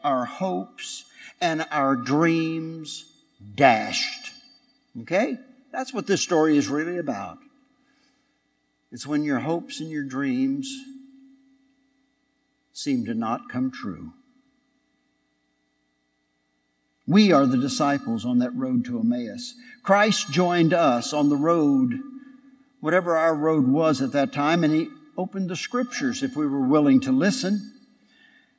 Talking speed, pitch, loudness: 125 wpm, 240 Hz, -23 LUFS